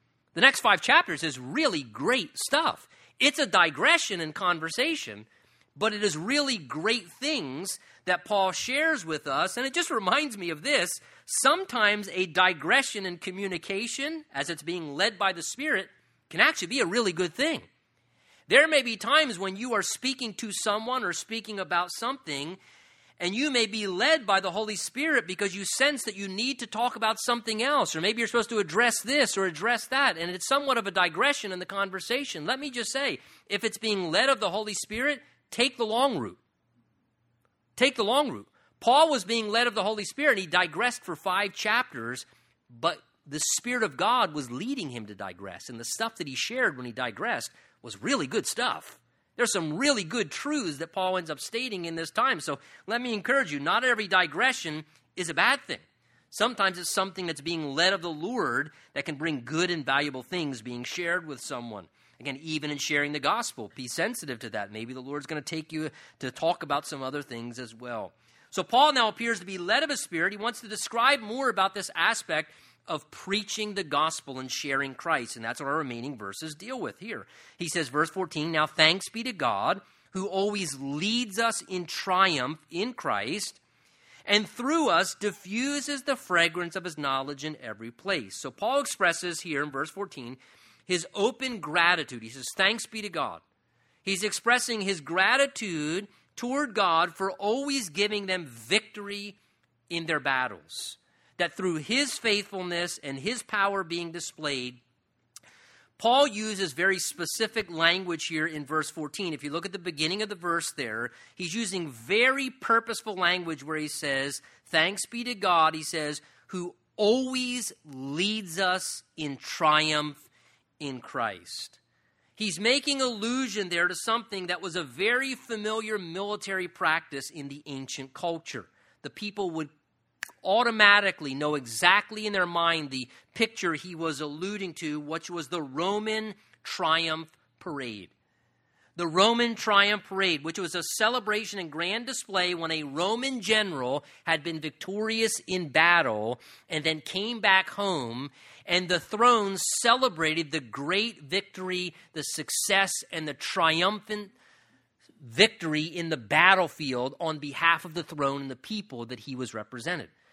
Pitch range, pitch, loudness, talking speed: 155-220 Hz, 185 Hz, -27 LUFS, 175 wpm